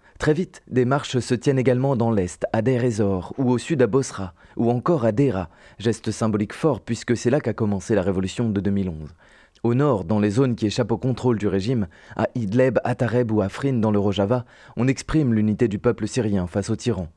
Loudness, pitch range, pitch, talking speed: -22 LUFS, 105-125 Hz, 115 Hz, 220 wpm